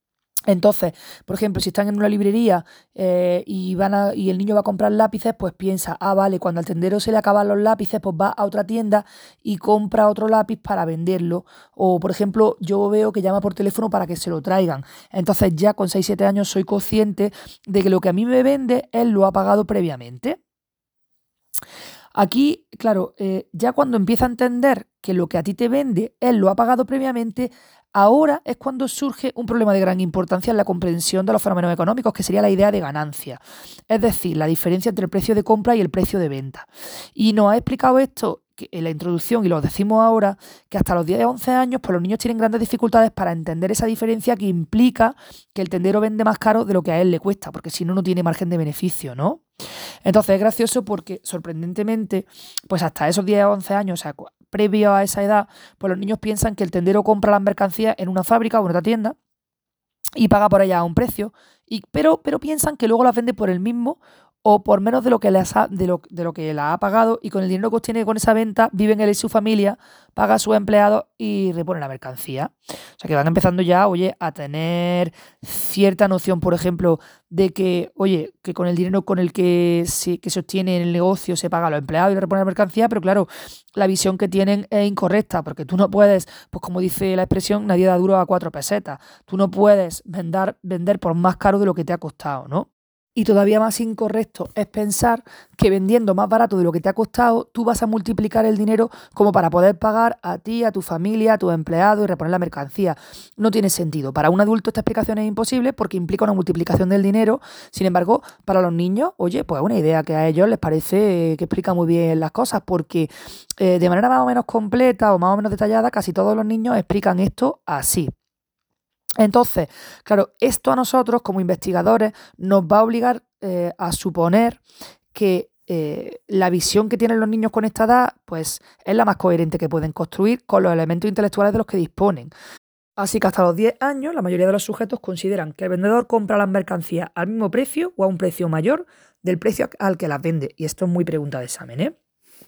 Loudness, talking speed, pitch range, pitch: -19 LUFS, 225 wpm, 180-220 Hz, 200 Hz